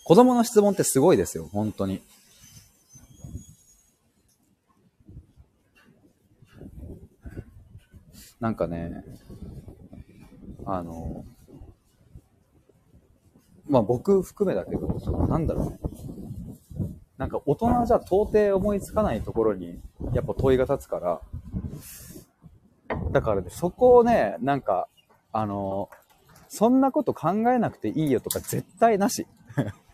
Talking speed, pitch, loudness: 195 characters per minute, 130 Hz, -24 LUFS